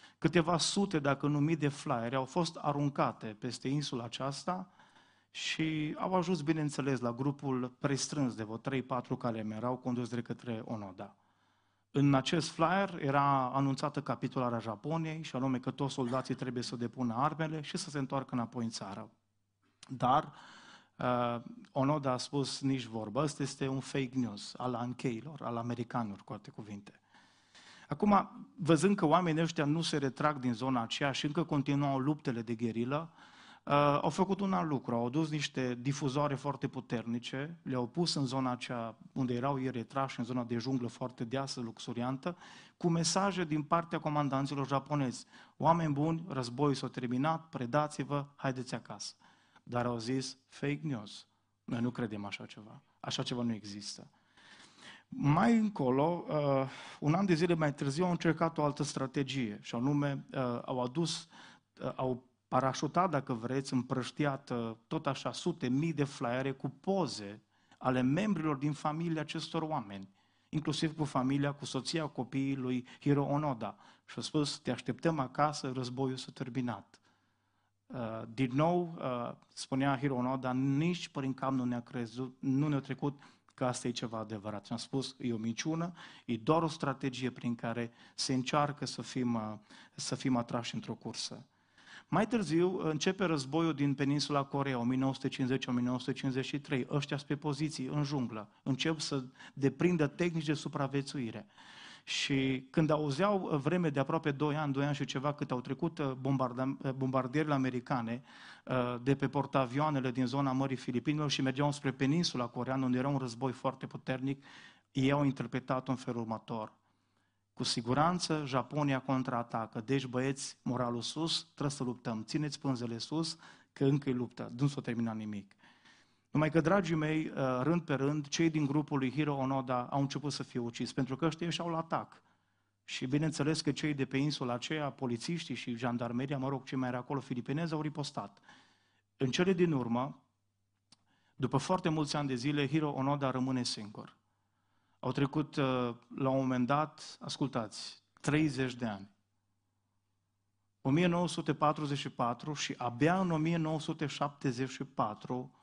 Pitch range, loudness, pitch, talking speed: 125-150 Hz, -35 LUFS, 135 Hz, 150 wpm